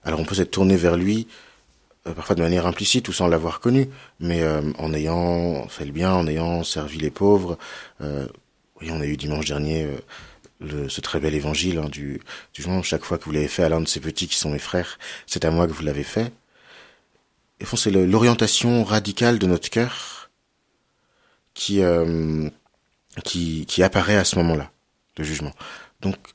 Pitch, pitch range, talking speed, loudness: 85 Hz, 75-95 Hz, 200 wpm, -22 LUFS